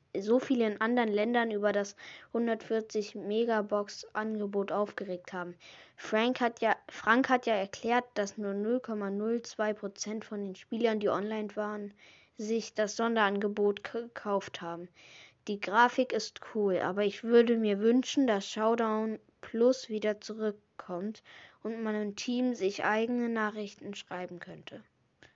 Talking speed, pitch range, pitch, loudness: 130 wpm, 205-230 Hz, 215 Hz, -31 LUFS